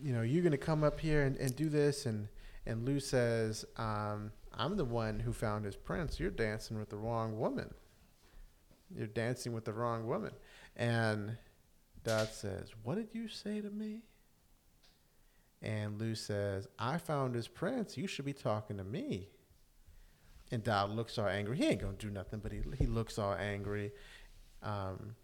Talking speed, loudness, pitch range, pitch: 180 wpm, -38 LUFS, 105-130 Hz, 110 Hz